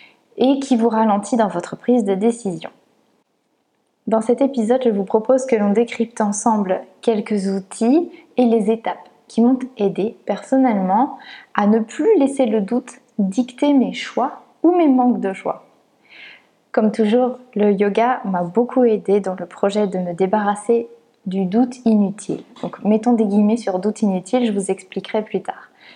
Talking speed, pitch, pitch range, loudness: 160 wpm, 225 Hz, 205-245 Hz, -18 LUFS